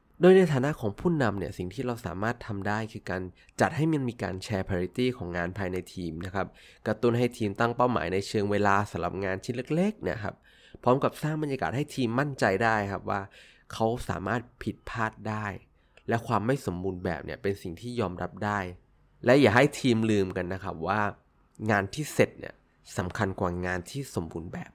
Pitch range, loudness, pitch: 95-125 Hz, -29 LUFS, 105 Hz